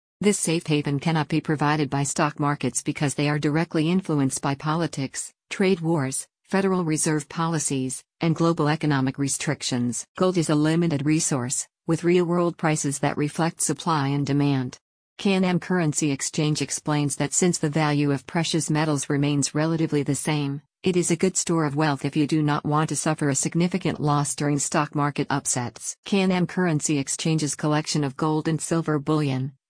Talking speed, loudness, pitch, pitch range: 170 wpm, -24 LUFS, 150 Hz, 145-165 Hz